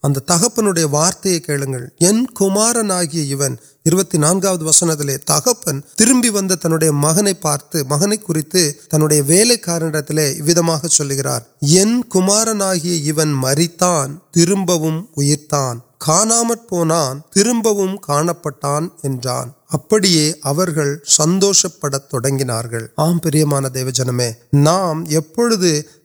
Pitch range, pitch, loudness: 145-185 Hz, 160 Hz, -15 LUFS